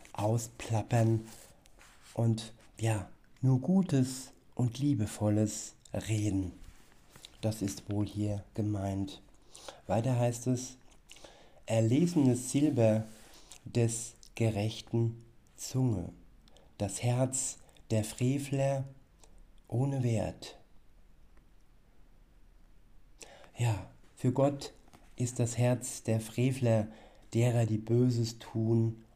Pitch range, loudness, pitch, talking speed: 105-125 Hz, -32 LUFS, 115 Hz, 80 wpm